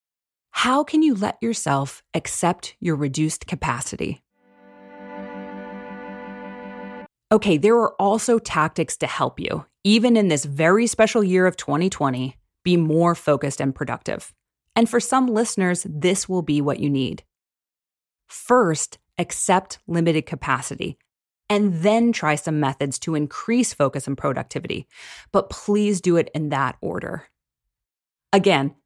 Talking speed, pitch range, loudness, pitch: 130 wpm, 135-205 Hz, -21 LUFS, 165 Hz